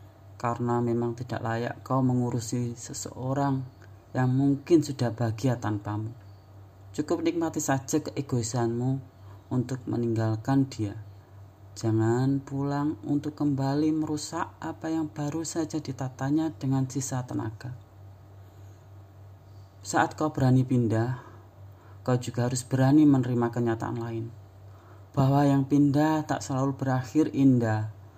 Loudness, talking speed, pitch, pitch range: -27 LUFS, 105 wpm, 125 Hz, 105-140 Hz